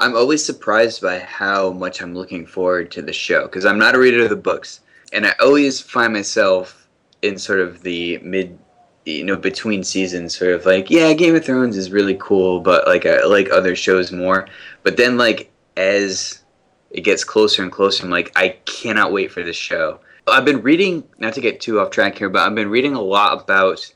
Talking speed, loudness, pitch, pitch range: 210 wpm, -16 LUFS, 95 Hz, 90-105 Hz